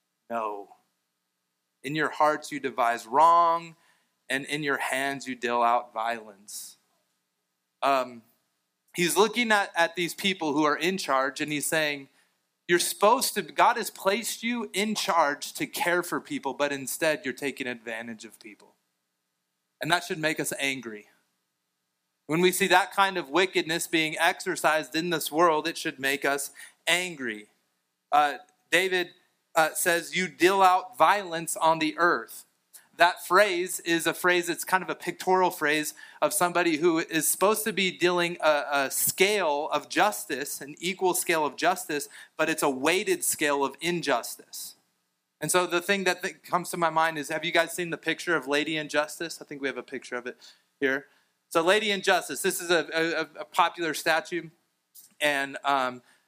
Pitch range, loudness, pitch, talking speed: 130-175 Hz, -26 LUFS, 155 Hz, 170 wpm